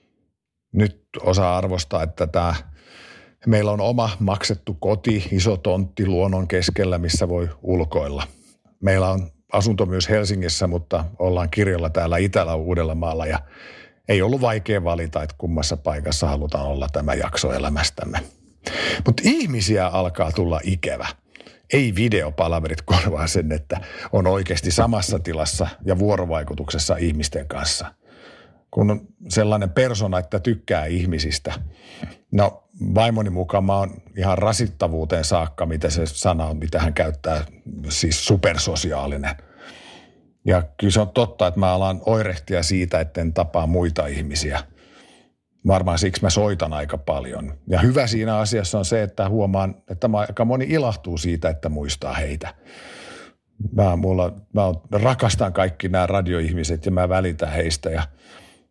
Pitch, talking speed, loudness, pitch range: 90 Hz, 135 wpm, -21 LUFS, 80-100 Hz